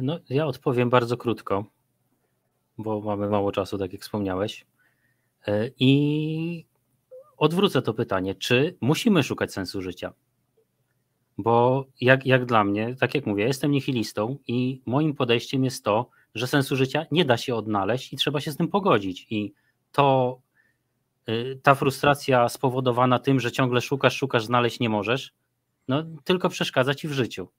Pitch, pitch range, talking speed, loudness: 125 Hz, 110-140 Hz, 150 wpm, -24 LUFS